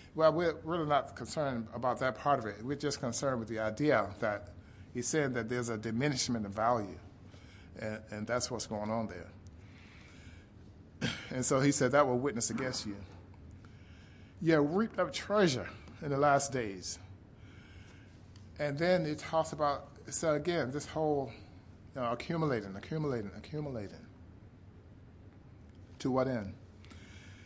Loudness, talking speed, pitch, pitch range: -34 LUFS, 145 wpm, 115 Hz, 100-140 Hz